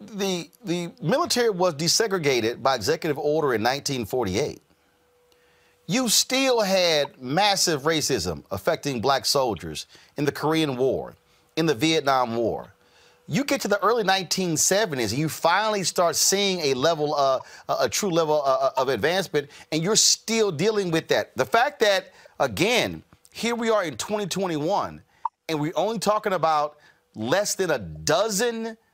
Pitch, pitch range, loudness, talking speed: 170 Hz, 150-210 Hz, -23 LUFS, 145 wpm